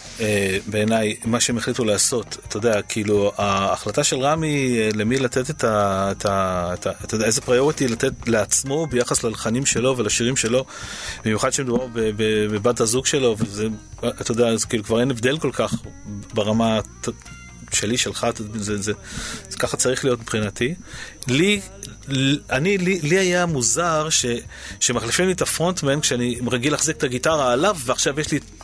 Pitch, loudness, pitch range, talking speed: 120 Hz, -21 LUFS, 105-135 Hz, 155 wpm